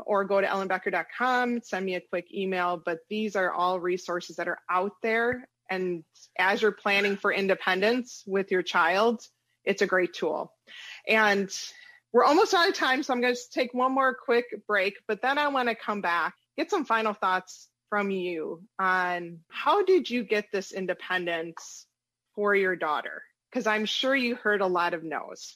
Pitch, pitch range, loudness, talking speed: 200 Hz, 185-240 Hz, -27 LUFS, 185 wpm